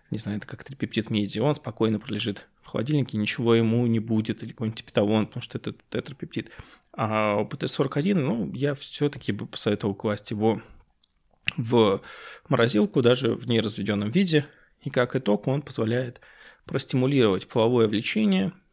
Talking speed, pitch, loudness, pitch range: 145 wpm, 115 Hz, -25 LUFS, 105-130 Hz